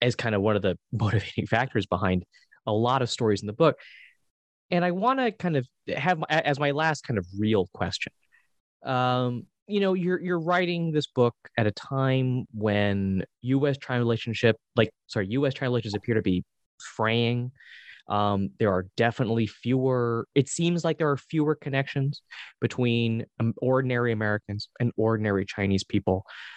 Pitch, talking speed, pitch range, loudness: 120 Hz, 165 wpm, 105-140 Hz, -26 LUFS